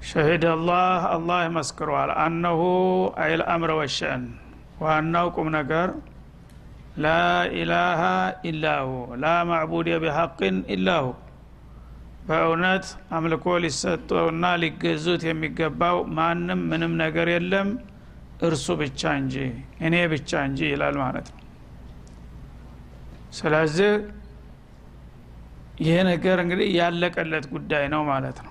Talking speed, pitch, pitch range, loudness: 95 wpm, 160 Hz, 135-175 Hz, -23 LUFS